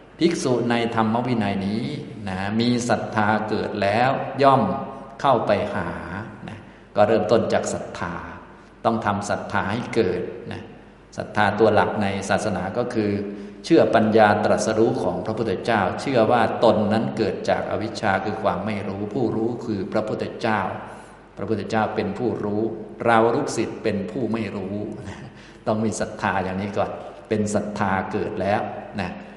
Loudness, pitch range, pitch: -22 LUFS, 100-110 Hz, 105 Hz